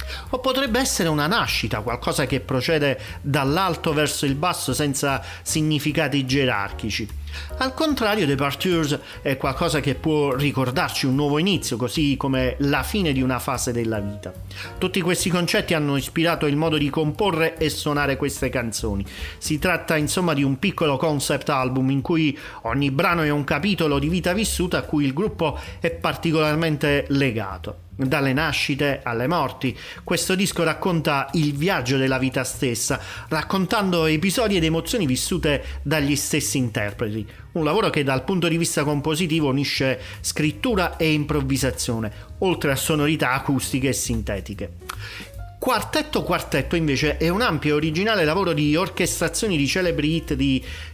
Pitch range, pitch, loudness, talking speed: 130-165 Hz, 145 Hz, -22 LUFS, 145 wpm